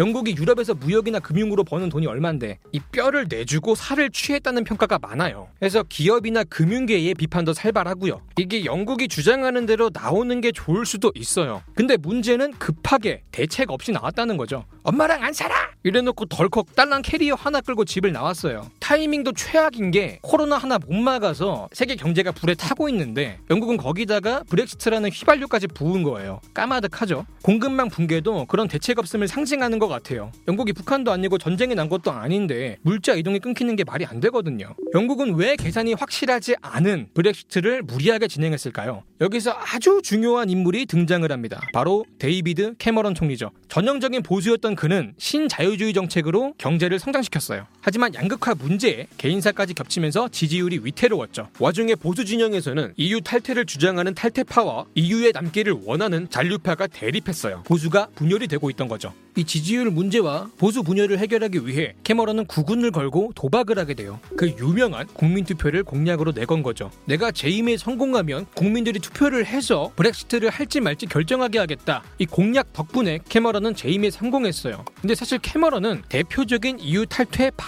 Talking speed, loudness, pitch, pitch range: 405 characters per minute, -22 LUFS, 200 Hz, 165-235 Hz